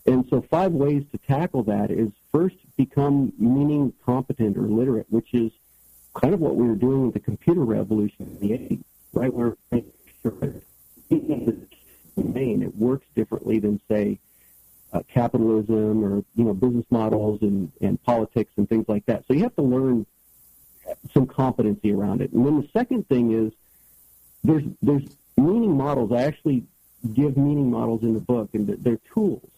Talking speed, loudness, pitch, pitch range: 160 wpm, -23 LUFS, 115 Hz, 105-135 Hz